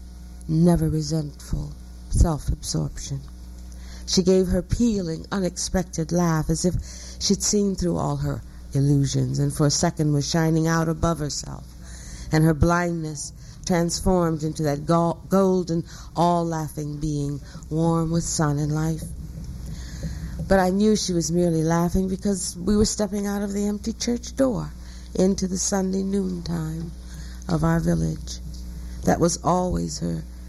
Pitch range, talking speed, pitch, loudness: 135-180 Hz, 140 wpm, 160 Hz, -23 LUFS